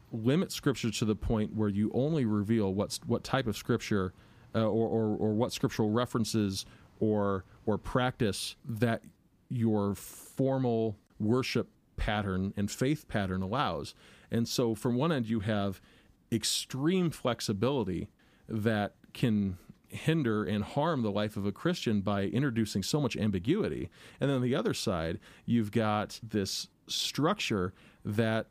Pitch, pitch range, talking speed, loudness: 110 Hz, 105-120 Hz, 145 wpm, -32 LUFS